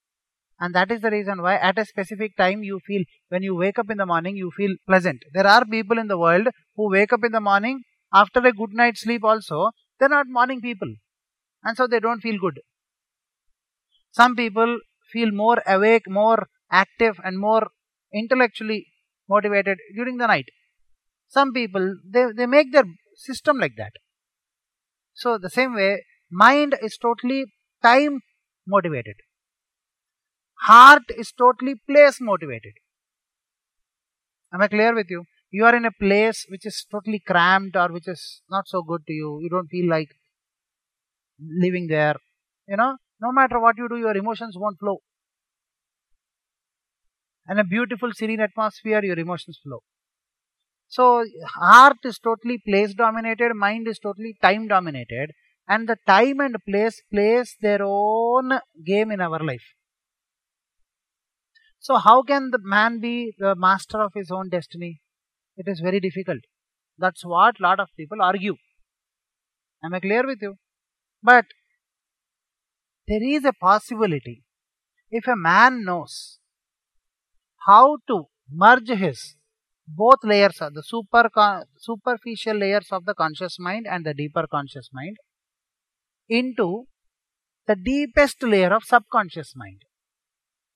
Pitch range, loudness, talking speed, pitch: 185-235 Hz, -19 LUFS, 145 wpm, 210 Hz